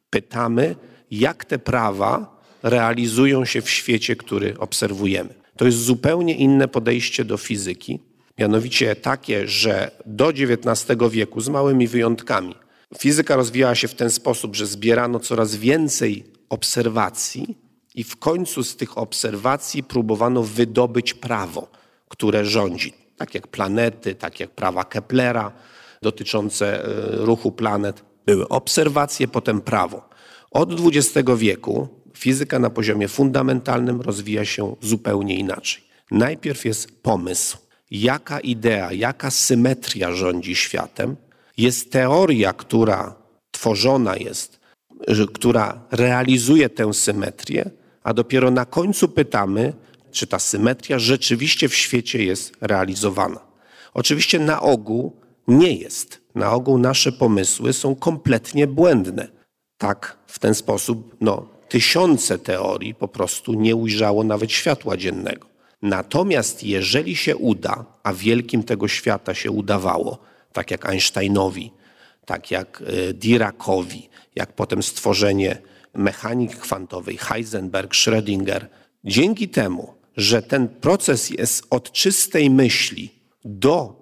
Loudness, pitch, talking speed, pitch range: -20 LUFS, 115 Hz, 115 wpm, 105-130 Hz